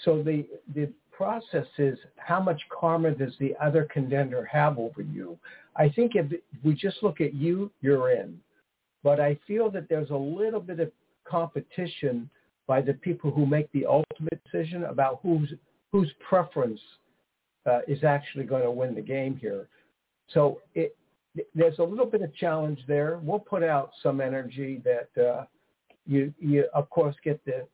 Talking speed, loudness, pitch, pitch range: 170 wpm, -28 LUFS, 150 Hz, 140-170 Hz